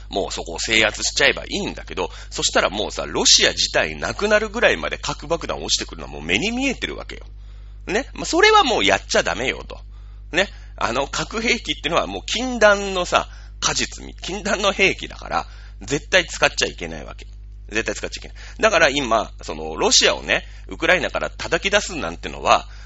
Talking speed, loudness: 375 characters per minute, -19 LUFS